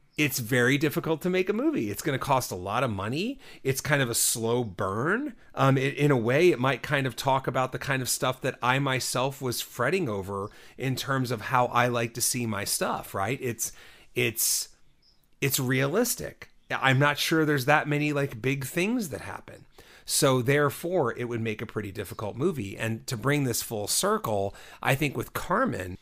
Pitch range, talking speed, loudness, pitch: 120-150 Hz, 200 wpm, -27 LUFS, 130 Hz